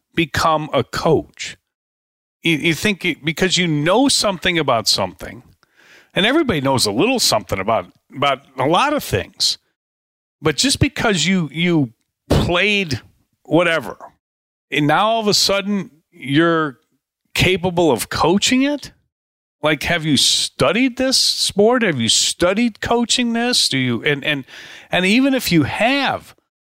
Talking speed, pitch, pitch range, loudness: 140 wpm, 170 Hz, 140-210 Hz, -17 LUFS